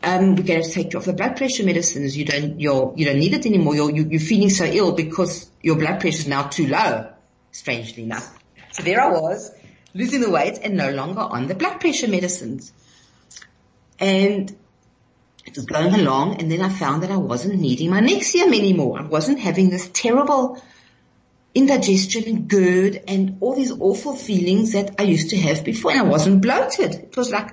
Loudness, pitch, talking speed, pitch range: -19 LUFS, 190 Hz, 200 wpm, 165-215 Hz